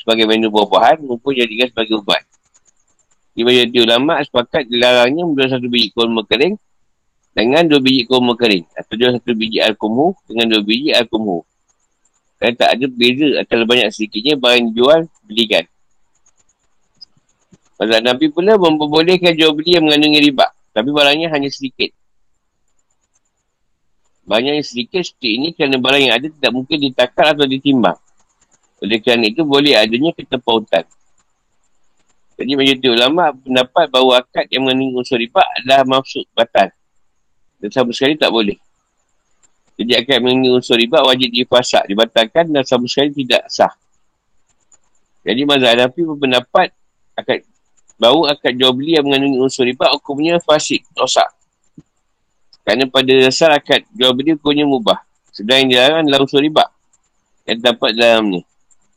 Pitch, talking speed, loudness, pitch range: 130 Hz, 140 wpm, -13 LUFS, 115-145 Hz